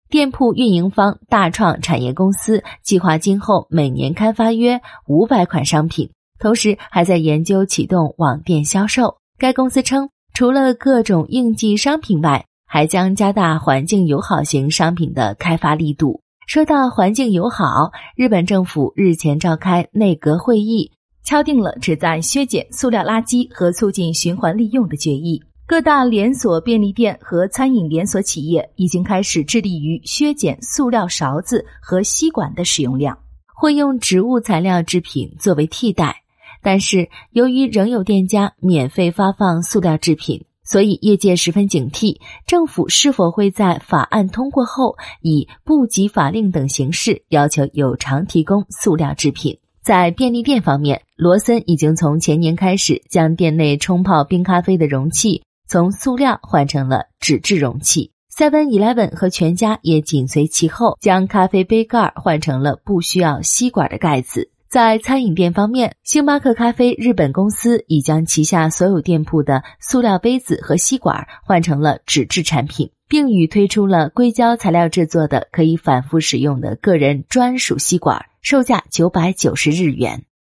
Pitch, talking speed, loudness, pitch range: 185 Hz, 260 characters per minute, -16 LUFS, 160-225 Hz